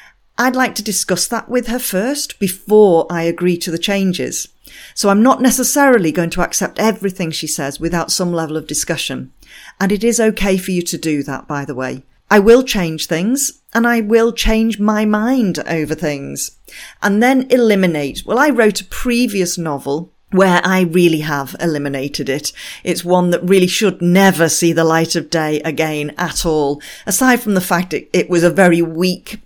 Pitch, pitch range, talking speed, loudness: 180 Hz, 160-220 Hz, 185 wpm, -15 LUFS